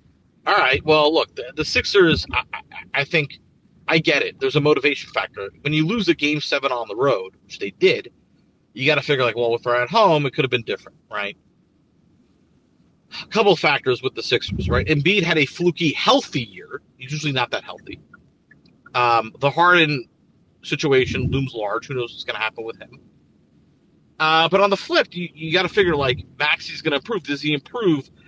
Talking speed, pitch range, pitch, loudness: 200 wpm, 130-170 Hz, 150 Hz, -20 LUFS